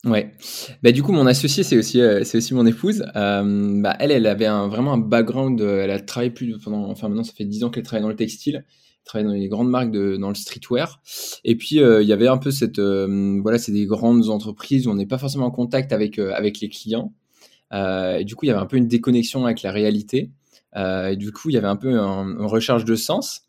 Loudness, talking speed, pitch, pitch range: -20 LUFS, 260 wpm, 110 Hz, 100-125 Hz